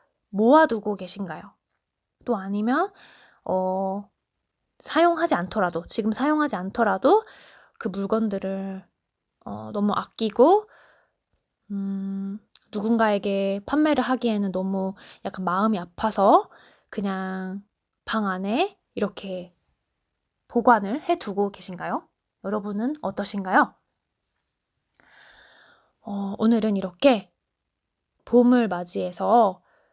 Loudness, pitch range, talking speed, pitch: -24 LUFS, 190-240 Hz, 210 characters per minute, 205 Hz